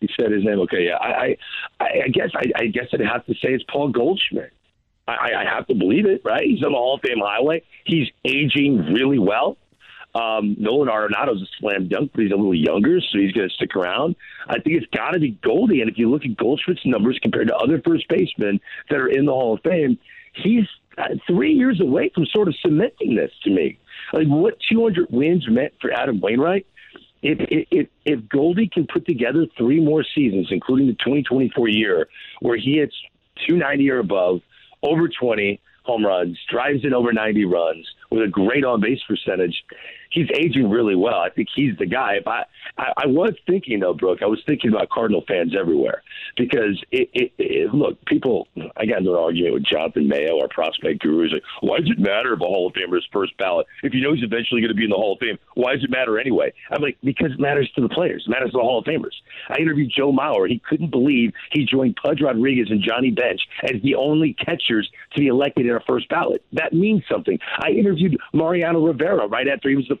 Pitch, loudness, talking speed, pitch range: 145 Hz, -20 LUFS, 220 wpm, 120-200 Hz